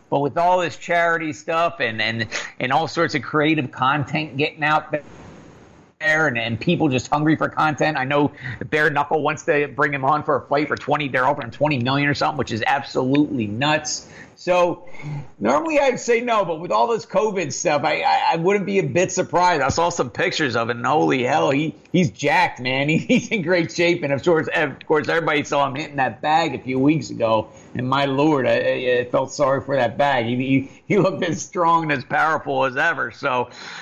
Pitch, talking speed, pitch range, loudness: 150 Hz, 220 wpm, 135-170 Hz, -20 LUFS